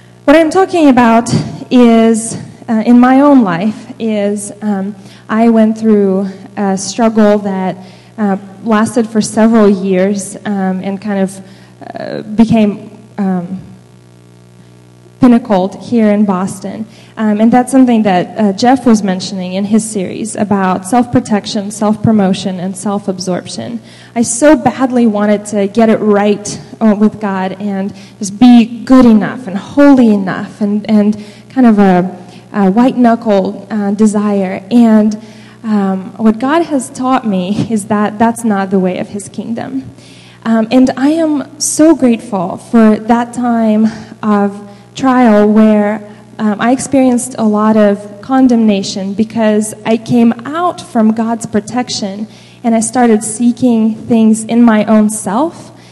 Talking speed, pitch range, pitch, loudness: 140 wpm, 200-235 Hz, 215 Hz, -11 LUFS